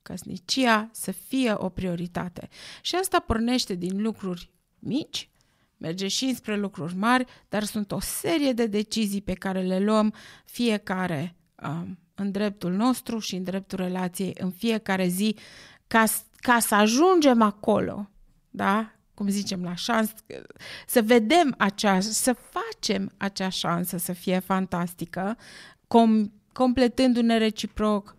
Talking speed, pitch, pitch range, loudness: 130 wpm, 205 Hz, 185-230 Hz, -25 LUFS